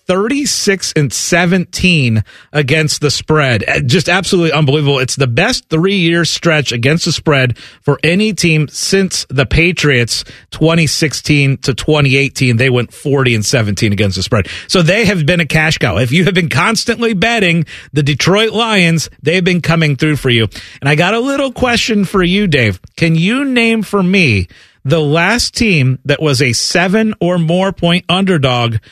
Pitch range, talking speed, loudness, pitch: 135-185 Hz, 170 wpm, -12 LUFS, 160 Hz